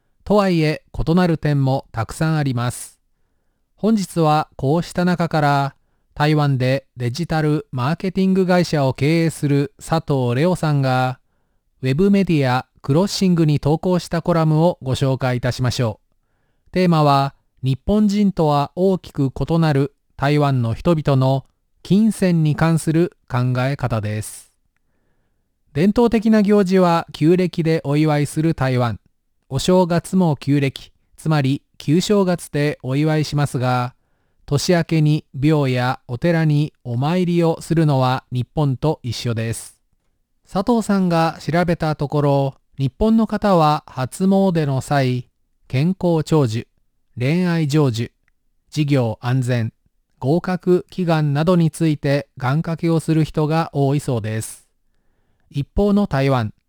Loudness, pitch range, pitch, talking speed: -19 LUFS, 130-170 Hz, 150 Hz, 255 characters per minute